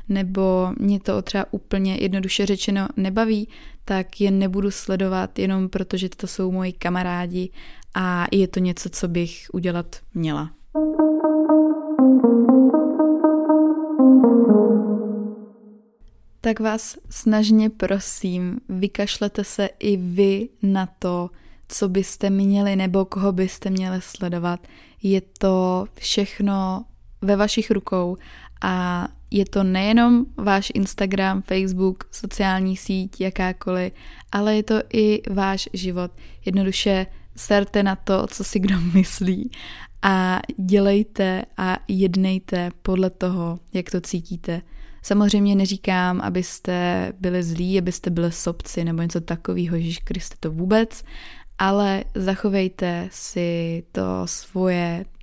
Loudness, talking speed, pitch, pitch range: -21 LUFS, 115 wpm, 195 Hz, 185-210 Hz